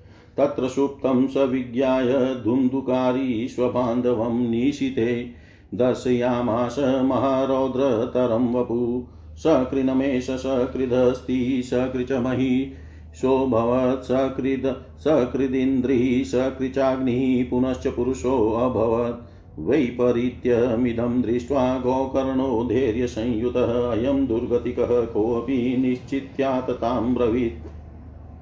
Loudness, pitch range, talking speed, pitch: -22 LUFS, 120-130 Hz, 55 wpm, 125 Hz